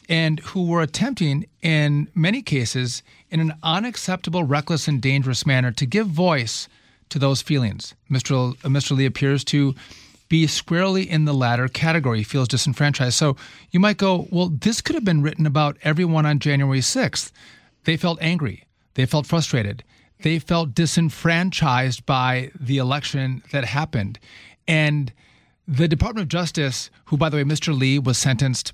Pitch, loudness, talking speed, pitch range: 145 Hz, -21 LUFS, 155 wpm, 130-165 Hz